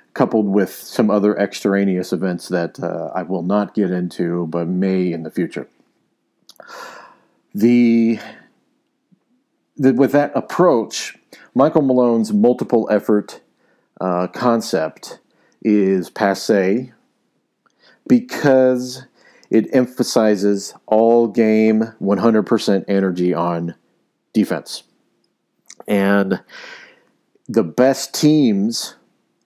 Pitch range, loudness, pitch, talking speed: 95-125 Hz, -17 LUFS, 110 Hz, 90 wpm